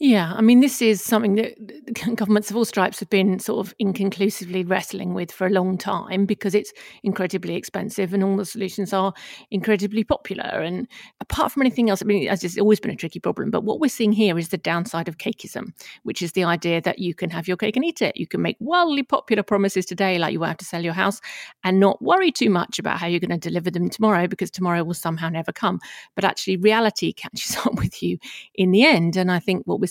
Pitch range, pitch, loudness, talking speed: 180-215 Hz, 195 Hz, -22 LUFS, 240 wpm